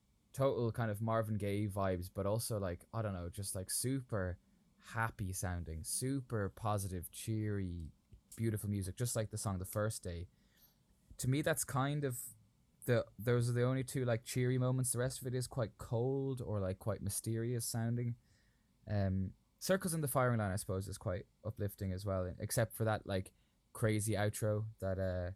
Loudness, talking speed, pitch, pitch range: -38 LUFS, 180 wpm, 110 Hz, 95-120 Hz